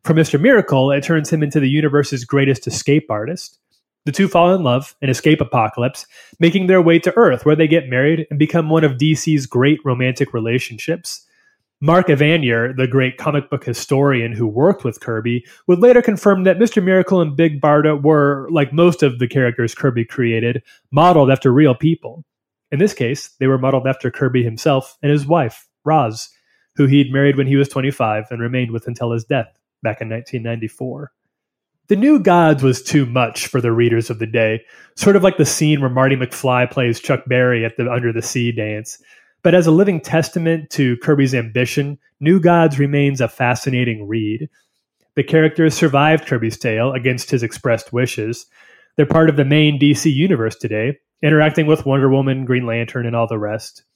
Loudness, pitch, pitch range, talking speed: -16 LUFS, 140 Hz, 125-155 Hz, 185 wpm